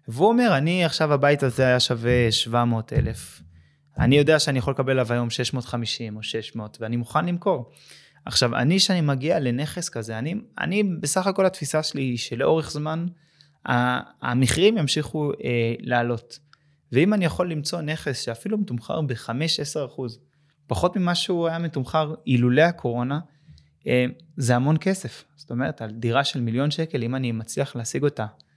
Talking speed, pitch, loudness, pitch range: 155 wpm, 140 Hz, -23 LUFS, 120-160 Hz